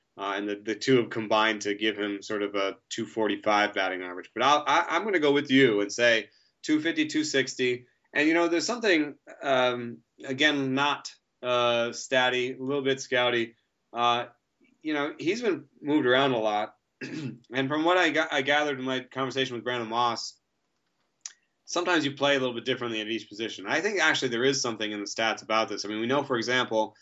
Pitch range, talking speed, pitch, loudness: 110-140 Hz, 205 wpm, 125 Hz, -26 LUFS